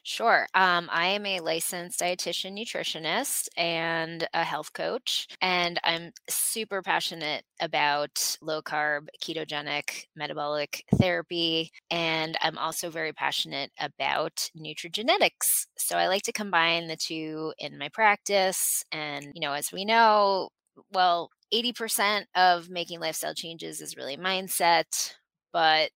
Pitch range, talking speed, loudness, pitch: 155-185 Hz, 125 wpm, -27 LUFS, 170 Hz